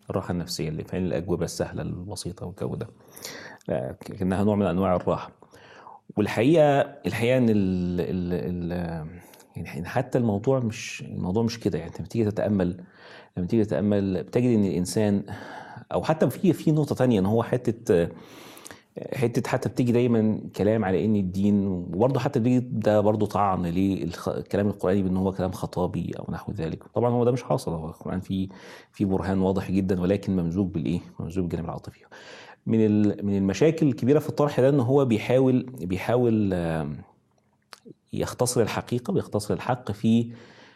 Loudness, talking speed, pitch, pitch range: -25 LUFS, 150 wpm, 105 Hz, 95-120 Hz